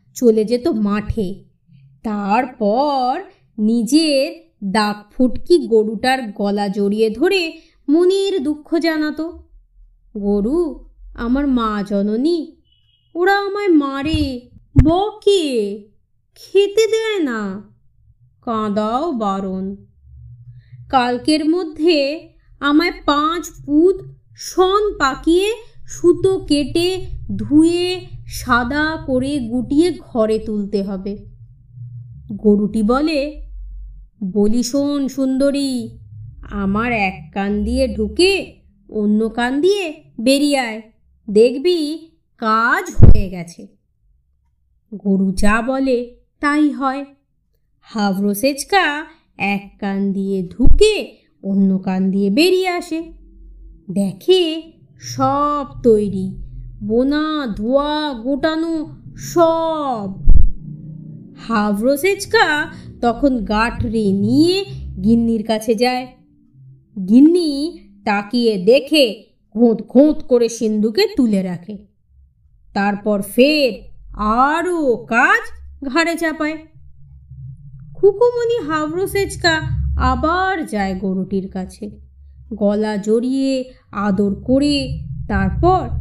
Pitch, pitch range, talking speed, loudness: 245 Hz, 200-310 Hz, 80 wpm, -17 LUFS